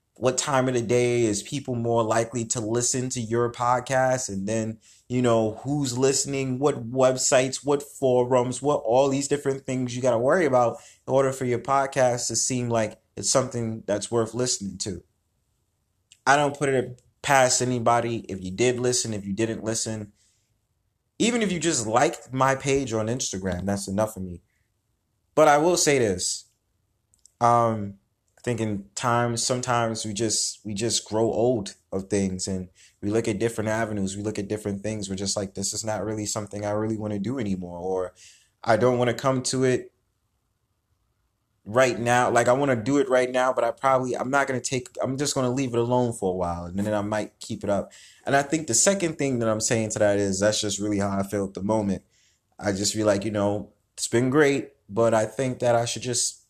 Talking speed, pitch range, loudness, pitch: 210 wpm, 105-125 Hz, -24 LUFS, 115 Hz